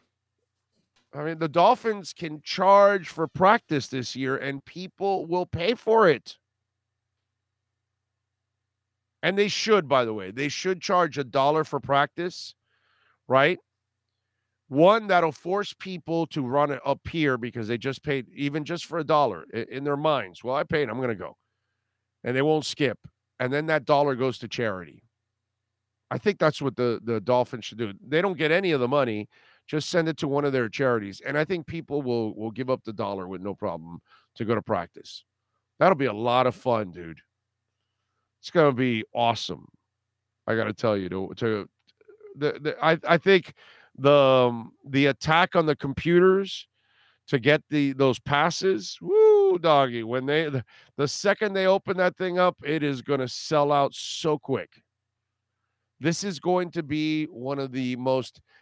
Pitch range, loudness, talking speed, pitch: 110-160 Hz, -25 LUFS, 175 wpm, 135 Hz